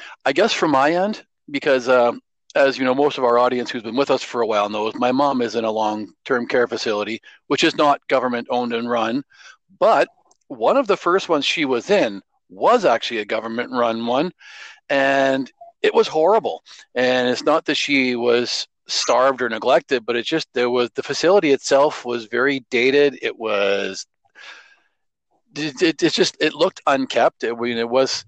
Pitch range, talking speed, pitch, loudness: 120-145 Hz, 195 wpm, 125 Hz, -19 LUFS